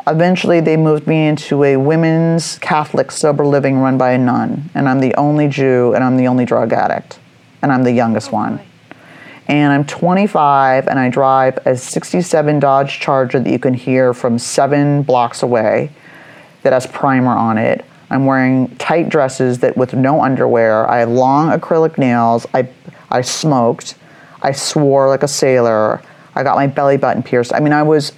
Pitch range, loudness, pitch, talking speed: 125-150 Hz, -13 LUFS, 135 Hz, 180 wpm